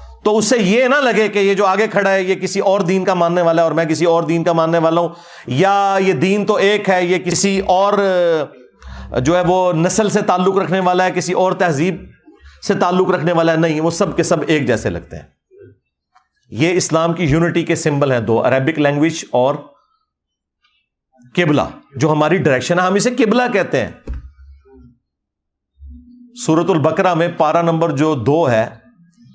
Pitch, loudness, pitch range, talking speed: 175 Hz, -15 LUFS, 155-190 Hz, 190 wpm